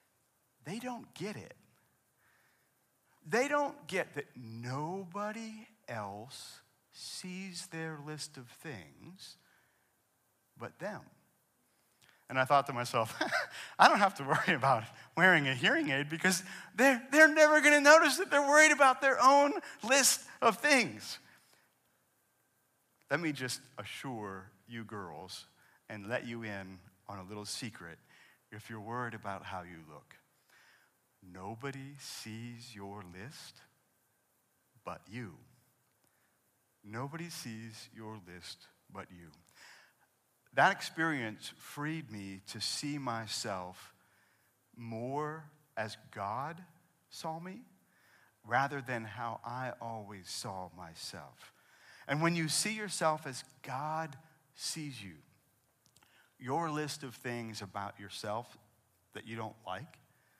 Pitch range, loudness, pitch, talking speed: 105-160 Hz, -32 LUFS, 125 Hz, 120 wpm